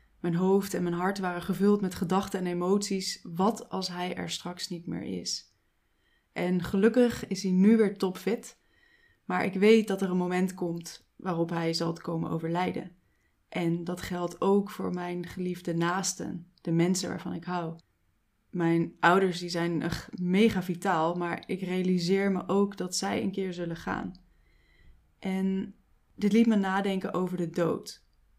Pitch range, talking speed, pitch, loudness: 170-195 Hz, 165 wpm, 180 Hz, -29 LUFS